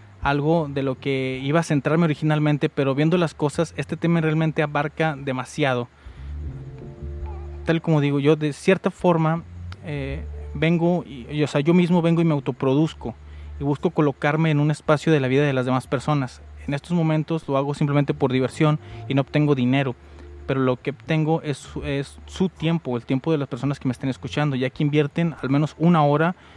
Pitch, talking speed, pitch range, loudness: 145 Hz, 190 wpm, 130-155 Hz, -22 LUFS